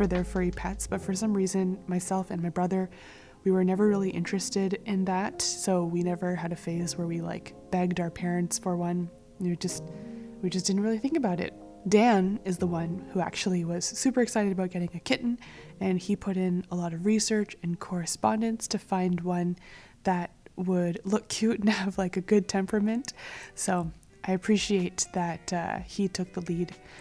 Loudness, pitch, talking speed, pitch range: -29 LUFS, 185 Hz, 190 wpm, 175-200 Hz